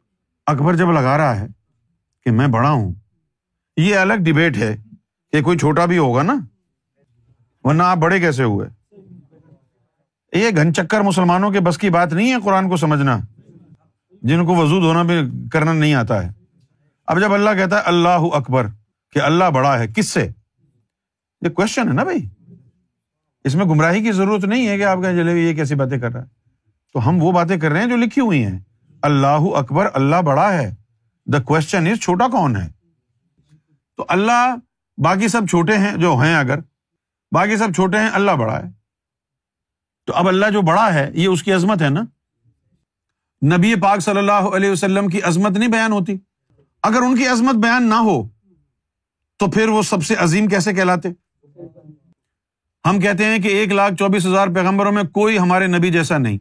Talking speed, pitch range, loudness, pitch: 180 wpm, 135-195 Hz, -16 LUFS, 170 Hz